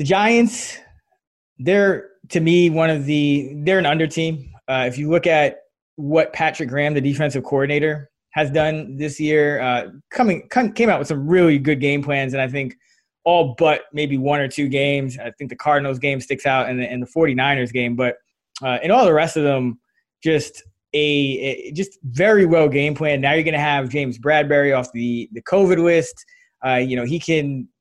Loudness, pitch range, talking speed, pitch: -19 LUFS, 135-165 Hz, 195 wpm, 145 Hz